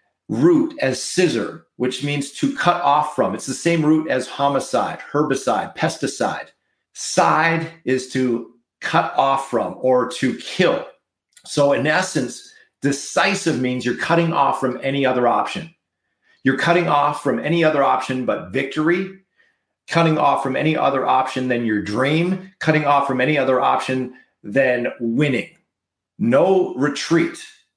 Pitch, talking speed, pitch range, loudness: 145 Hz, 145 wpm, 130-170 Hz, -19 LUFS